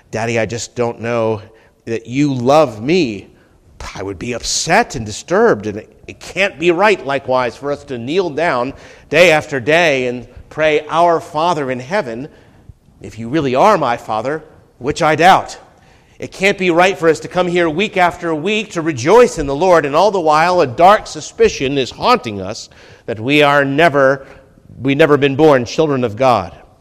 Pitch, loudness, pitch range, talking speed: 145 Hz, -14 LUFS, 120-170 Hz, 185 wpm